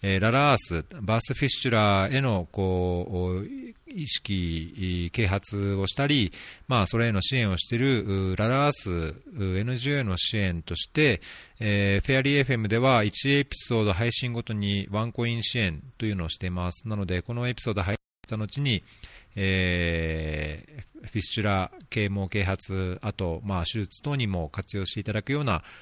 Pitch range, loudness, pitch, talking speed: 95-120 Hz, -27 LUFS, 105 Hz, 325 characters per minute